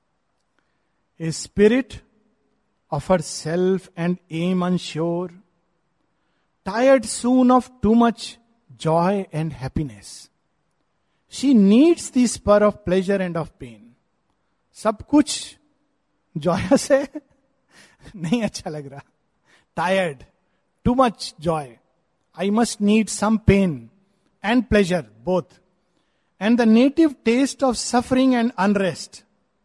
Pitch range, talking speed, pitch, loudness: 170-235 Hz, 100 wpm, 195 Hz, -20 LUFS